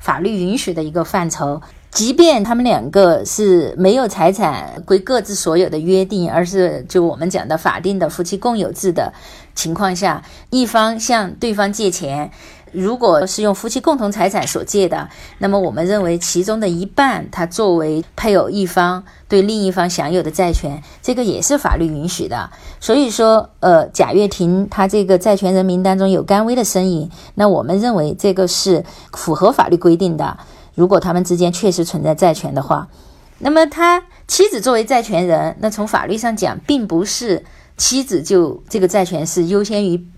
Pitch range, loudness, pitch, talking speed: 175-215 Hz, -15 LUFS, 190 Hz, 275 characters per minute